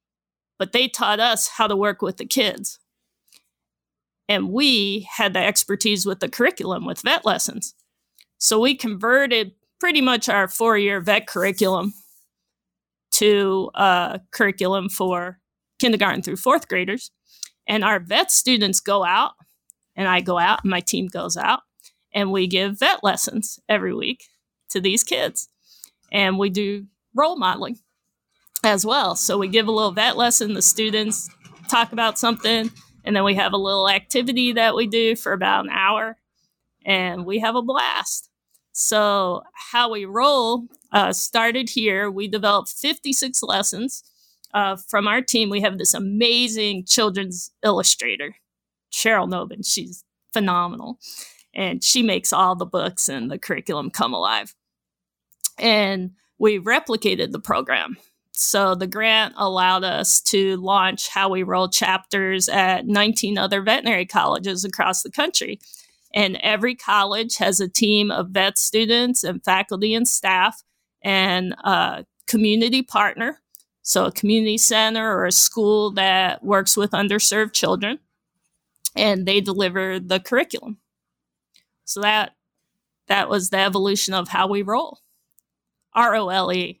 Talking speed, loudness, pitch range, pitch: 145 wpm, -19 LUFS, 195-225 Hz, 205 Hz